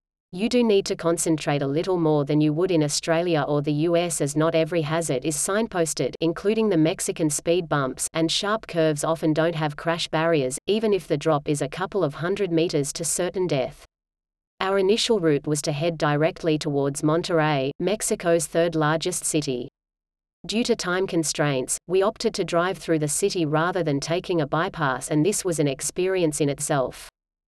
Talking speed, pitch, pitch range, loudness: 185 wpm, 160 Hz, 150-180 Hz, -23 LUFS